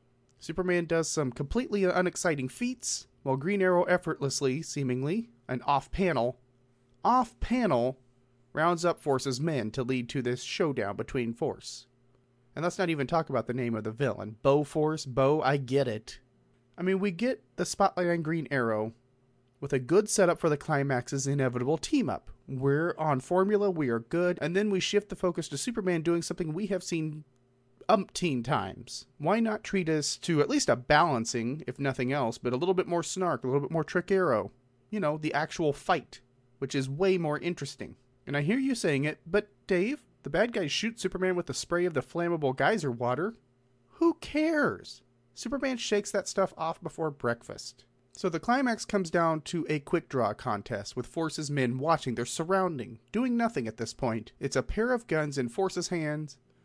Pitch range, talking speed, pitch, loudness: 125-180 Hz, 185 wpm, 150 Hz, -30 LUFS